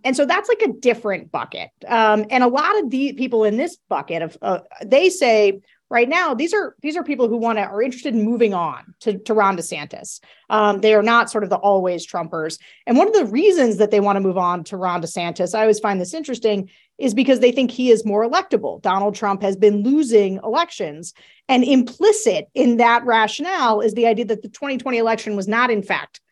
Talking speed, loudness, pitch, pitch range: 225 wpm, -18 LUFS, 225 Hz, 200-265 Hz